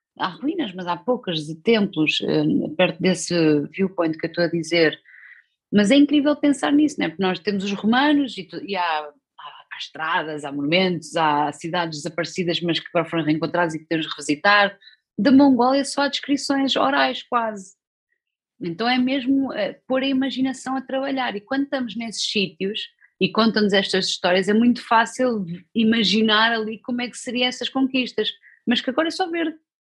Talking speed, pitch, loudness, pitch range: 180 wpm, 215 Hz, -21 LUFS, 175-265 Hz